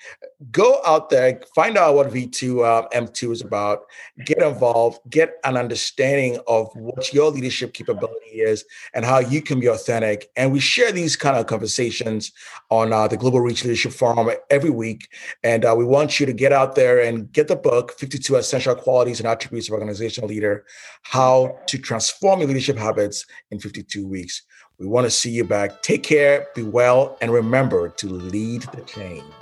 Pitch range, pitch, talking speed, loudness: 115-140 Hz, 125 Hz, 190 wpm, -19 LUFS